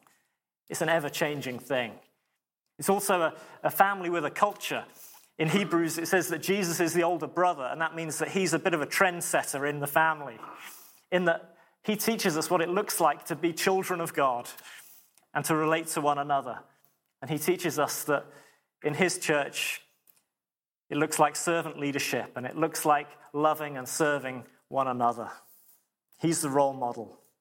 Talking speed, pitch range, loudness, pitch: 180 wpm, 145-175 Hz, -28 LUFS, 160 Hz